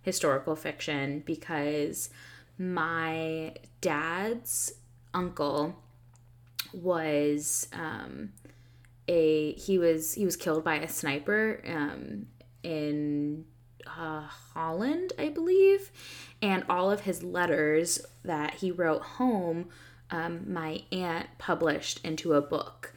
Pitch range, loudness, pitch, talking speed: 145-180 Hz, -30 LUFS, 160 Hz, 100 wpm